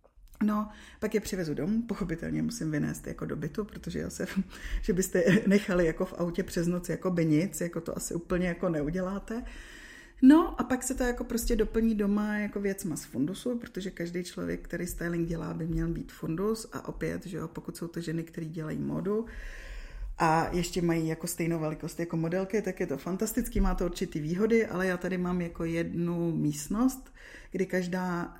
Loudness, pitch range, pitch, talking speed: -31 LUFS, 165-210 Hz, 180 Hz, 190 wpm